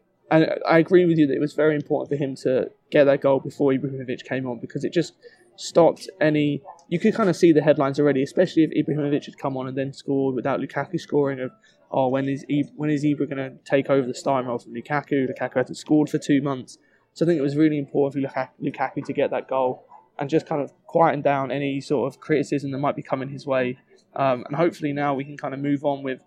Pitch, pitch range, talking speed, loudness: 145 Hz, 135-150 Hz, 245 wpm, -23 LUFS